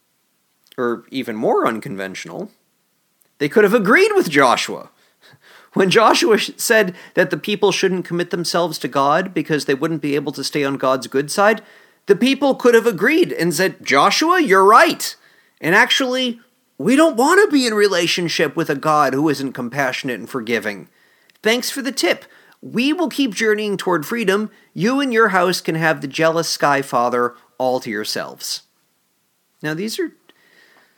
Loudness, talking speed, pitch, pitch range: -17 LUFS, 165 wpm, 190 Hz, 150-240 Hz